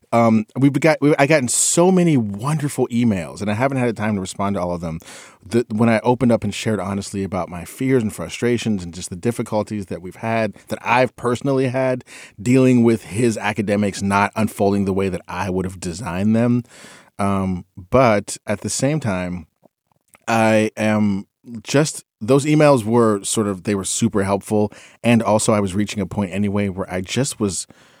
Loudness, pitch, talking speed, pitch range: -19 LUFS, 110 Hz, 195 wpm, 100-120 Hz